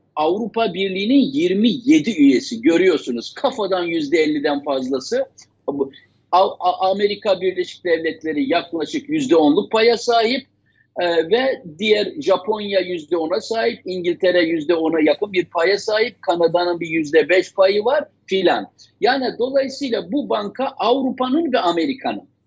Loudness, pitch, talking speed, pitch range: -19 LUFS, 200 Hz, 115 wpm, 170-255 Hz